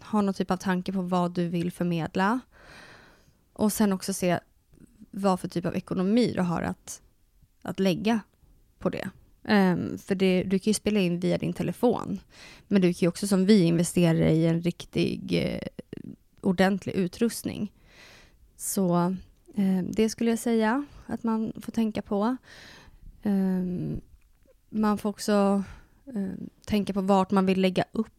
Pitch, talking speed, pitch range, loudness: 195 Hz, 160 wpm, 180-215 Hz, -27 LUFS